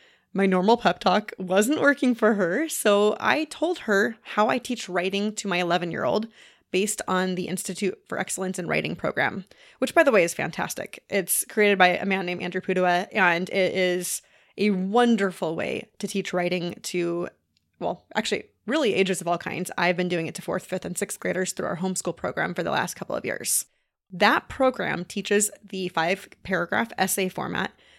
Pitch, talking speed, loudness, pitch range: 190 Hz, 190 wpm, -25 LUFS, 180-210 Hz